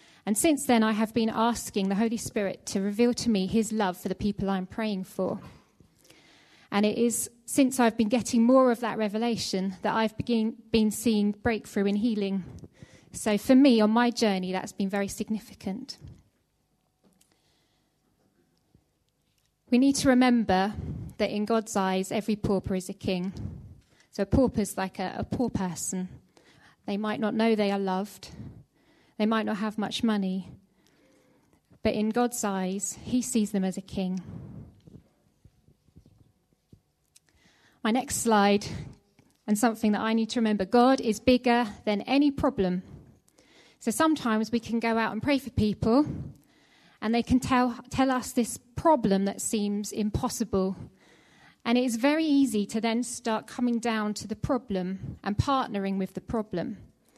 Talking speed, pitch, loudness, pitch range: 155 wpm, 220 Hz, -27 LUFS, 200-240 Hz